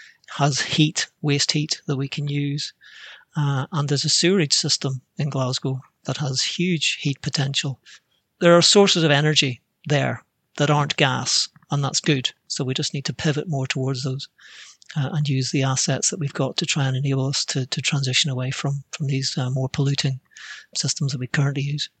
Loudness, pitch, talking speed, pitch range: -21 LUFS, 145 Hz, 190 wpm, 135-155 Hz